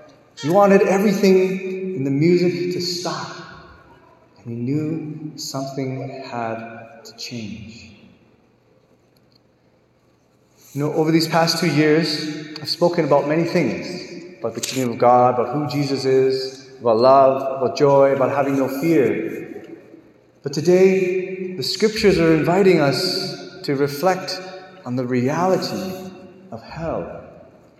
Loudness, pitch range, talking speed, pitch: -19 LUFS, 135-180 Hz, 125 wpm, 155 Hz